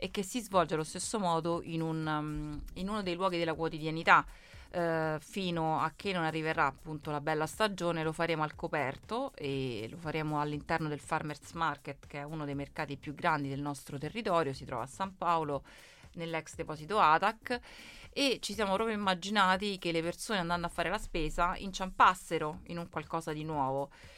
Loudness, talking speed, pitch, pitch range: -33 LUFS, 180 wpm, 165 Hz, 150-185 Hz